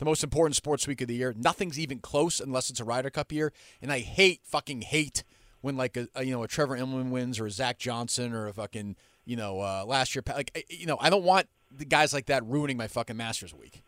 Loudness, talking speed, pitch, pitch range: -29 LUFS, 260 wpm, 130 Hz, 120-150 Hz